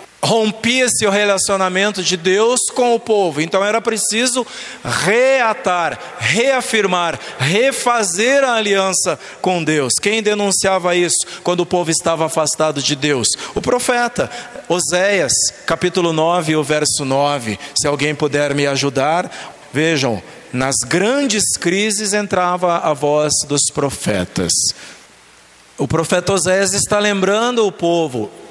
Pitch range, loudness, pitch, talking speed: 155-215 Hz, -15 LUFS, 185 Hz, 120 wpm